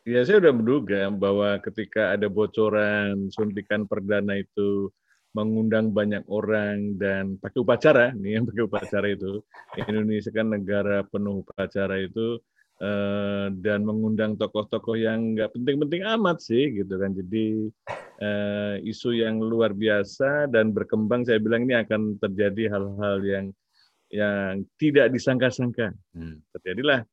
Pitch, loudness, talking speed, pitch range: 105 Hz, -25 LUFS, 125 wpm, 100-115 Hz